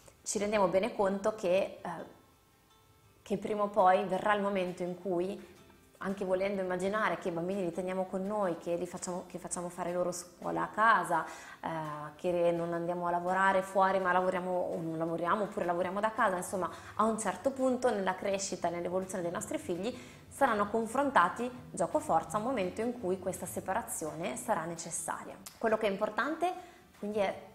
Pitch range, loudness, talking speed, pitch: 175-210 Hz, -33 LUFS, 175 wpm, 185 Hz